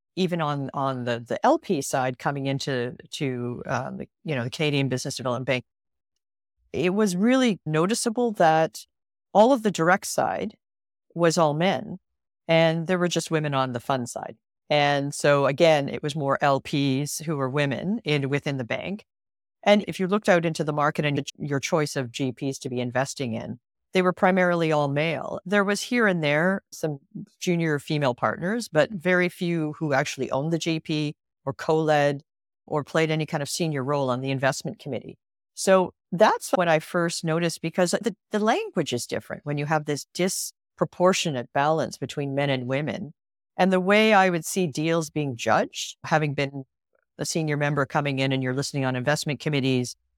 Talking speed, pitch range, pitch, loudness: 180 wpm, 135-180 Hz, 155 Hz, -24 LUFS